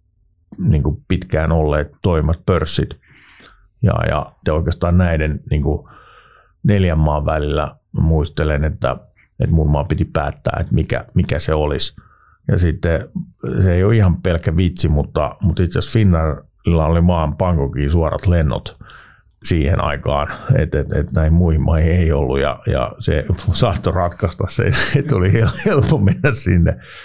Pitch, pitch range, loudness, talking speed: 85 Hz, 75-90 Hz, -17 LUFS, 145 wpm